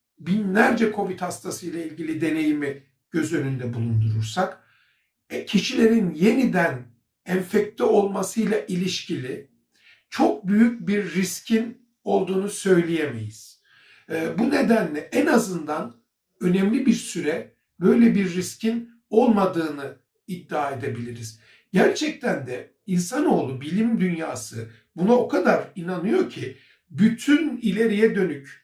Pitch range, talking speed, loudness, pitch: 155-225 Hz, 95 wpm, -23 LUFS, 185 Hz